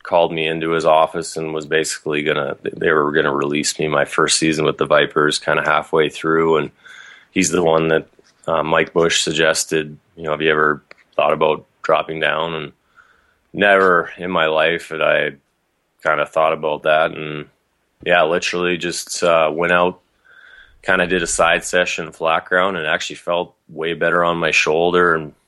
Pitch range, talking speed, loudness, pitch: 80-85 Hz, 190 wpm, -17 LUFS, 80 Hz